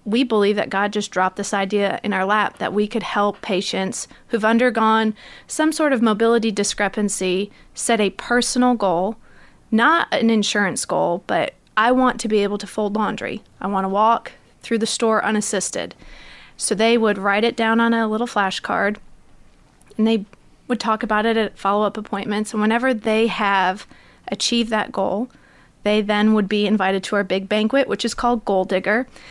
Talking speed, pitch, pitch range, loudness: 180 wpm, 215 Hz, 200-230 Hz, -20 LUFS